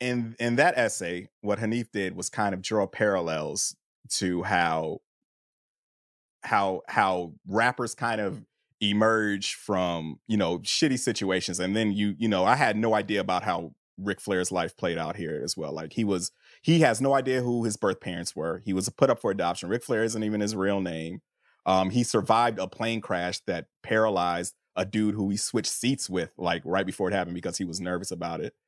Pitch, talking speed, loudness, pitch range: 100 Hz, 200 wpm, -27 LUFS, 90-115 Hz